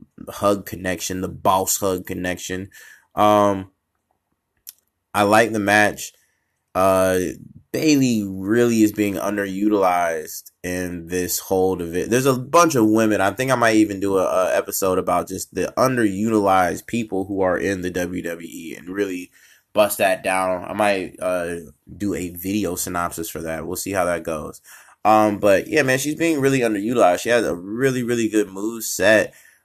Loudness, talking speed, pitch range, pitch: -20 LUFS, 160 wpm, 90-110 Hz, 100 Hz